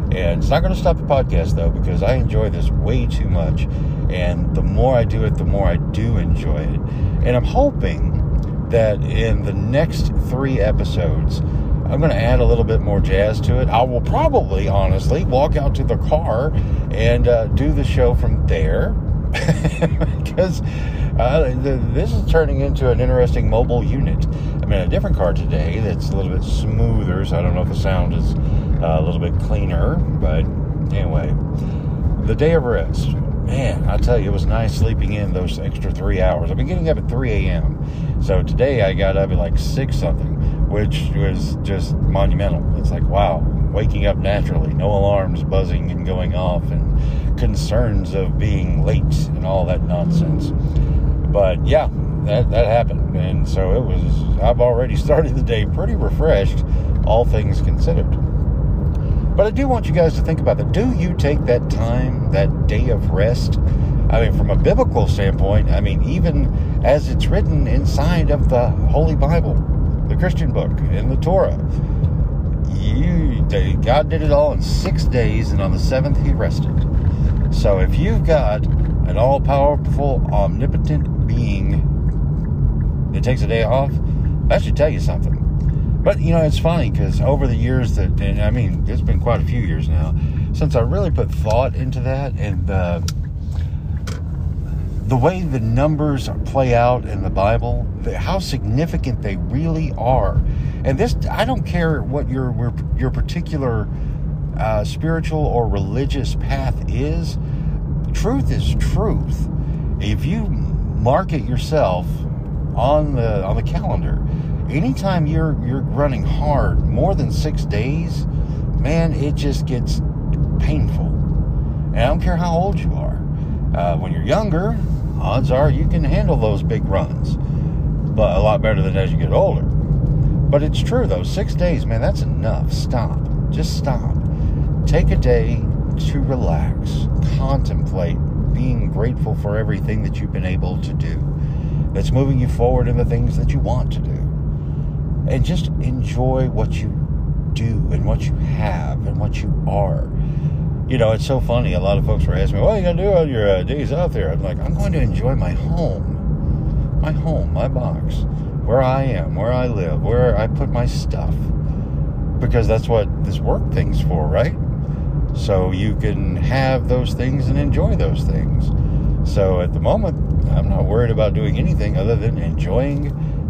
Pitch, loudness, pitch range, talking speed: 100 Hz, -18 LUFS, 80-125 Hz, 175 wpm